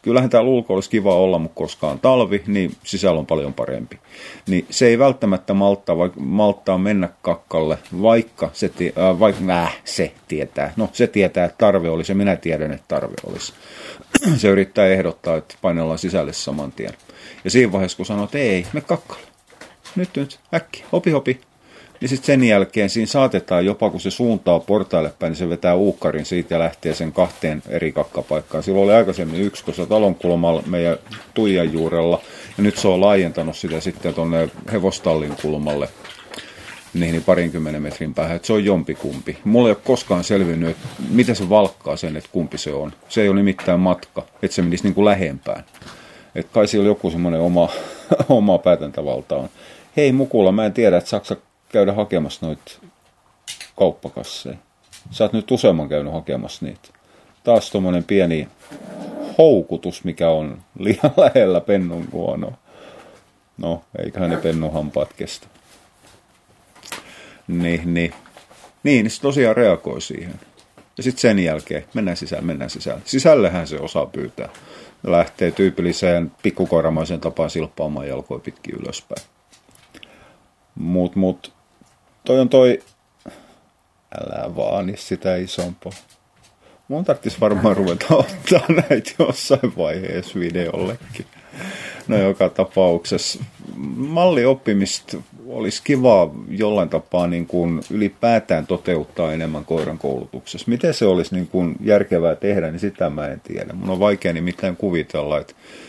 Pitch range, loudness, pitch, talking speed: 85-105 Hz, -19 LUFS, 95 Hz, 150 wpm